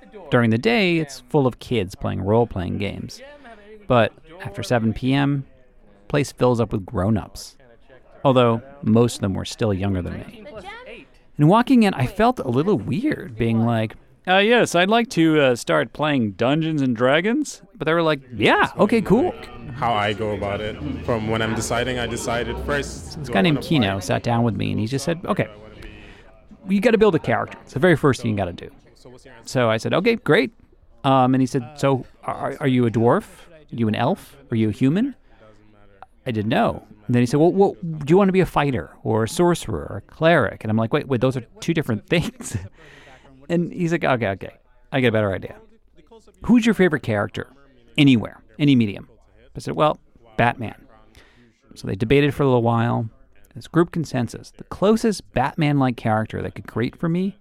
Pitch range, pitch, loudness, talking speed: 110-160 Hz, 125 Hz, -21 LUFS, 200 wpm